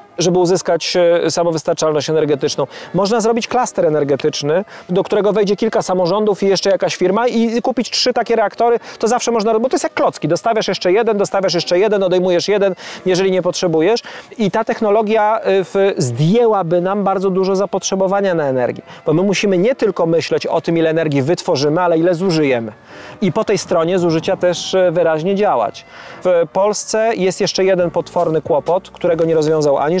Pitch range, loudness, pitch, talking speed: 170-210 Hz, -15 LUFS, 185 Hz, 170 wpm